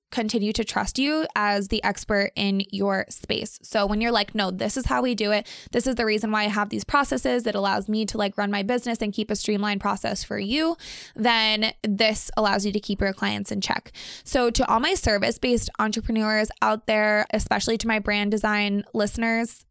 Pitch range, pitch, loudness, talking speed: 205-230 Hz, 215 Hz, -23 LUFS, 215 wpm